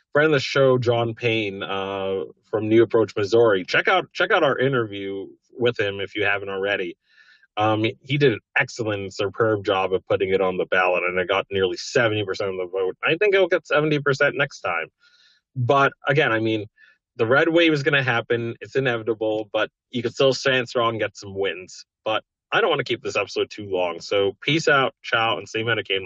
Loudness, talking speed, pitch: -22 LUFS, 215 wpm, 130 Hz